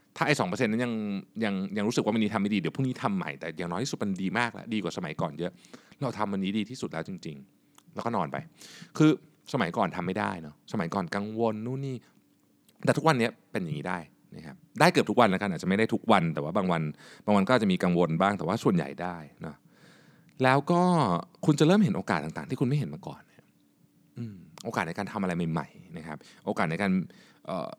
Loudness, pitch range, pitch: -28 LUFS, 95-130 Hz, 105 Hz